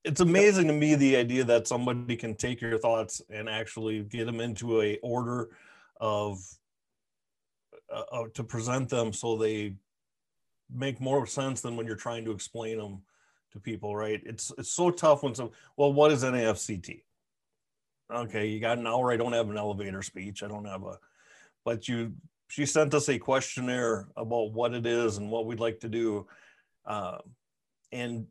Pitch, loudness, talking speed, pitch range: 115 Hz, -29 LUFS, 180 wpm, 110-125 Hz